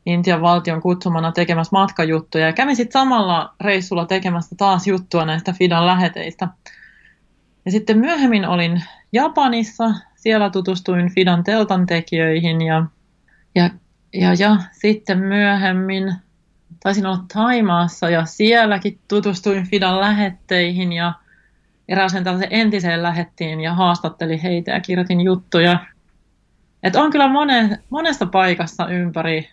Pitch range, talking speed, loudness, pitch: 175-205 Hz, 120 wpm, -17 LUFS, 185 Hz